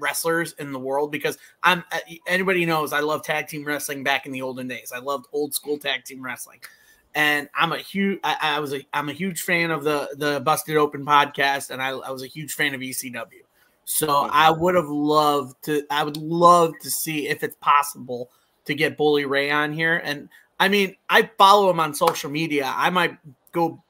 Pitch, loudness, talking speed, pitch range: 150 Hz, -22 LUFS, 210 wpm, 140-165 Hz